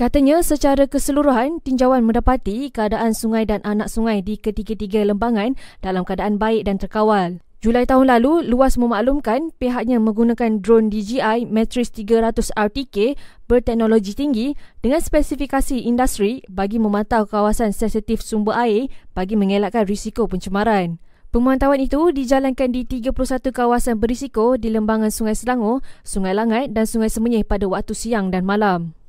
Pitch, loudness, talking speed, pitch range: 225 Hz, -19 LUFS, 135 wpm, 215-255 Hz